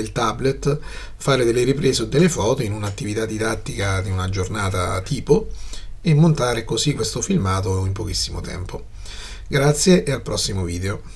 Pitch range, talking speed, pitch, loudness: 95-135 Hz, 145 wpm, 110 Hz, -20 LUFS